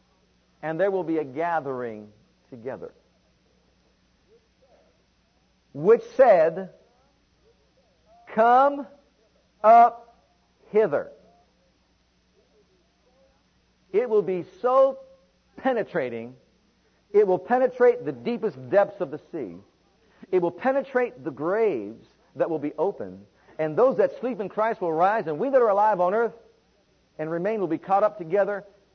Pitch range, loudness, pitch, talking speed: 170-255 Hz, -23 LUFS, 210 Hz, 120 wpm